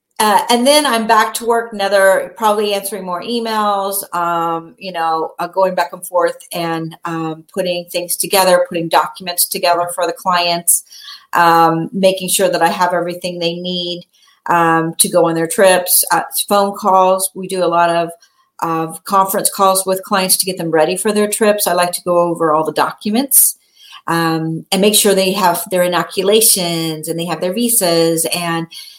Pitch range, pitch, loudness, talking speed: 170-200 Hz, 180 Hz, -14 LUFS, 180 wpm